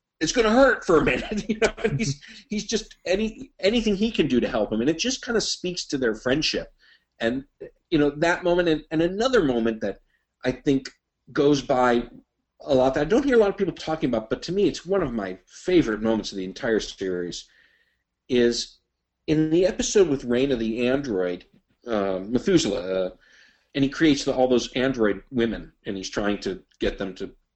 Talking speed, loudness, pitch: 205 wpm, -24 LUFS, 140 Hz